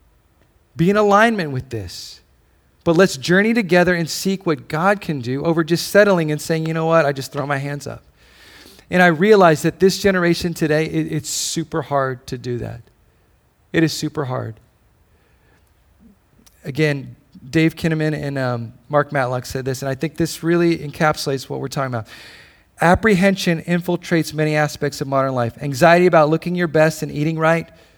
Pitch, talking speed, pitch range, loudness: 155 Hz, 175 wpm, 135-170 Hz, -18 LUFS